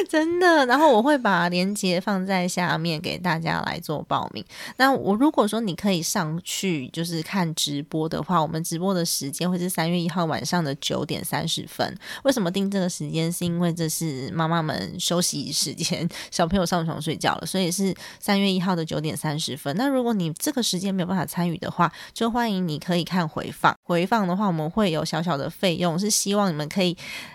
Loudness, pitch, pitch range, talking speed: -24 LUFS, 175 Hz, 165-195 Hz, 315 characters per minute